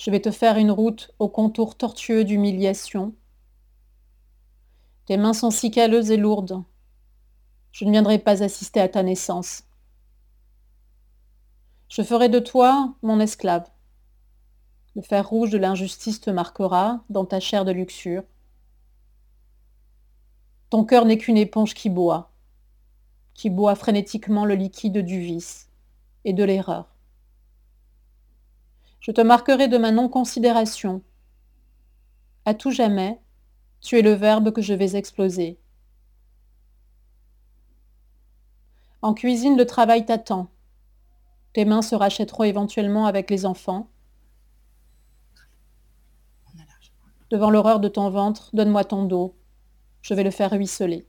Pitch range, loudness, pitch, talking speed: 190-220 Hz, -21 LUFS, 205 Hz, 120 wpm